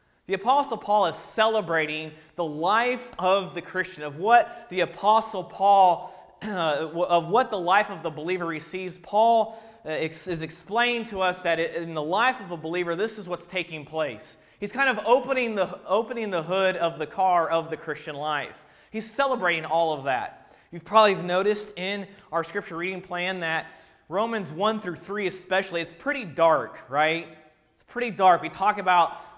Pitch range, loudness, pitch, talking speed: 165-210 Hz, -25 LUFS, 185 Hz, 175 wpm